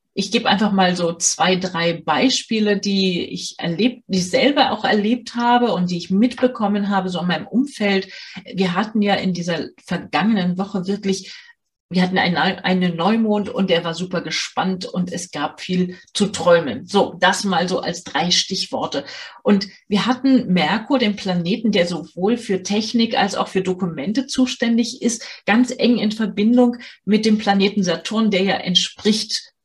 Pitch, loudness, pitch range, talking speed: 195 Hz, -19 LUFS, 185-230 Hz, 170 wpm